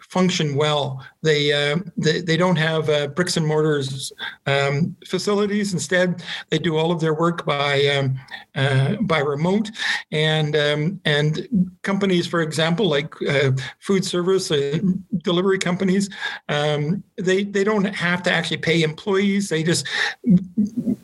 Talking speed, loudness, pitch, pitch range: 145 wpm, -21 LUFS, 170 Hz, 150-190 Hz